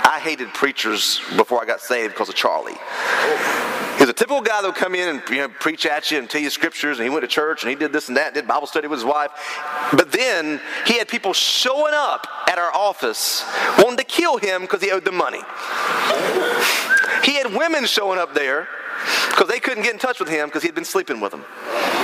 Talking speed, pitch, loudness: 230 wpm, 200 Hz, -19 LUFS